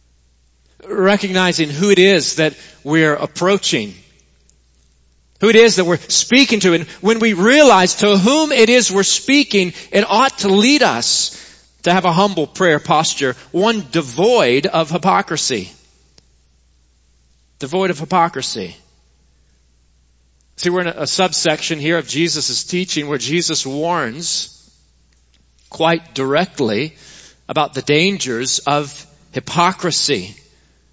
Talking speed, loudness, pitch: 120 wpm, -15 LUFS, 160 Hz